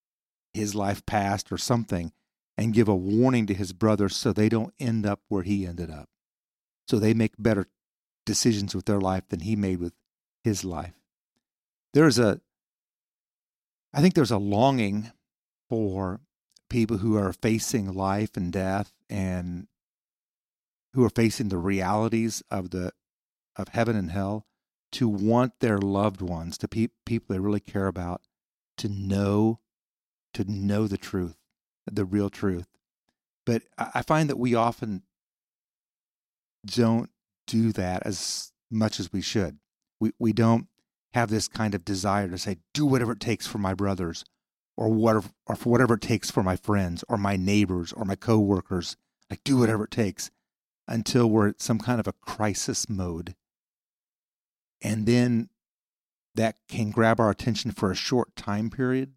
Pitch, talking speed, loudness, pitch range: 105 Hz, 160 wpm, -26 LUFS, 95-115 Hz